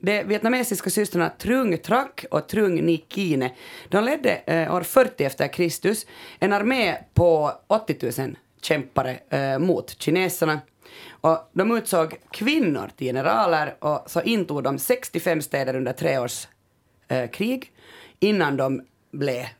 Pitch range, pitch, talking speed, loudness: 140-210 Hz, 170 Hz, 125 wpm, -23 LUFS